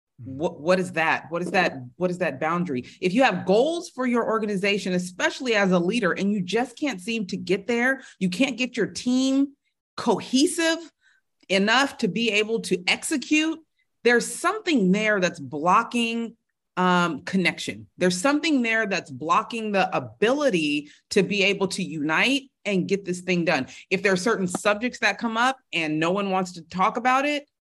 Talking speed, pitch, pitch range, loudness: 180 wpm, 205 Hz, 180-255 Hz, -23 LUFS